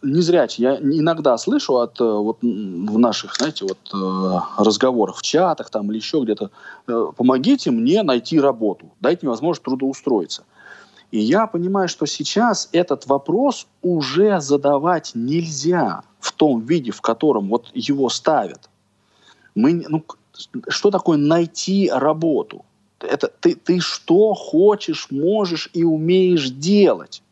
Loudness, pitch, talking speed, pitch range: -19 LUFS, 165 Hz, 130 wpm, 130-195 Hz